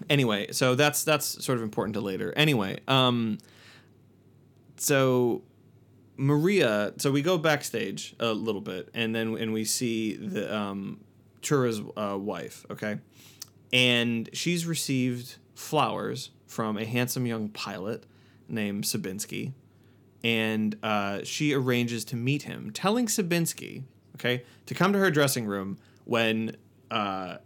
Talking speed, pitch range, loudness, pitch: 130 wpm, 110-135 Hz, -28 LUFS, 120 Hz